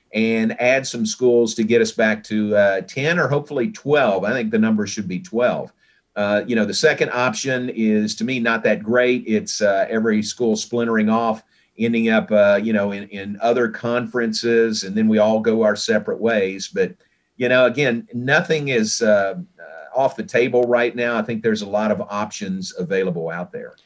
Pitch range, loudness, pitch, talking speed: 105-125 Hz, -19 LUFS, 115 Hz, 195 wpm